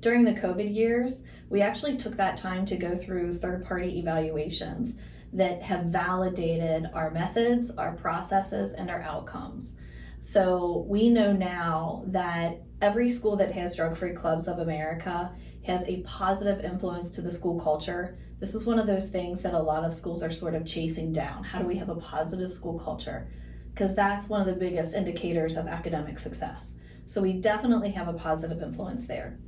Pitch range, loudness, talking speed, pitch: 165-195 Hz, -29 LUFS, 180 wpm, 180 Hz